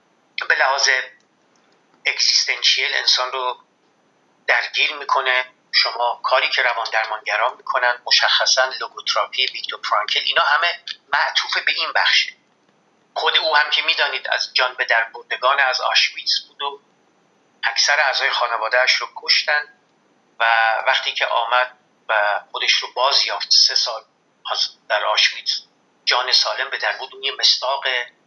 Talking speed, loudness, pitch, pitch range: 125 wpm, -18 LUFS, 125 Hz, 125-140 Hz